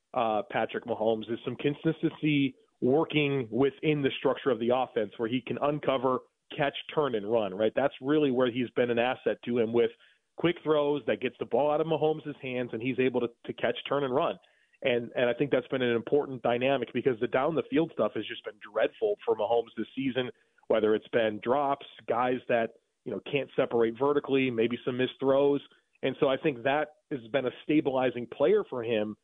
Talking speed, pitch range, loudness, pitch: 205 wpm, 120-145 Hz, -29 LUFS, 130 Hz